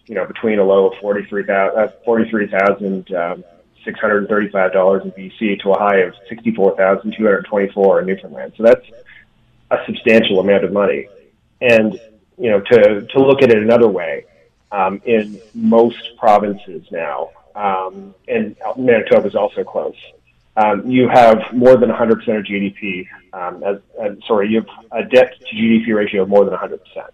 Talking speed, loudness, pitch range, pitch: 155 wpm, -15 LUFS, 100-120 Hz, 105 Hz